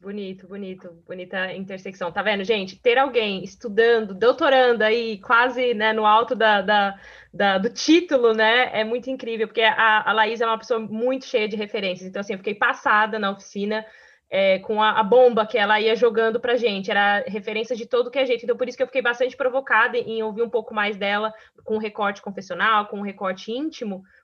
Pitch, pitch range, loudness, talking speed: 220 Hz, 205-240 Hz, -21 LUFS, 205 wpm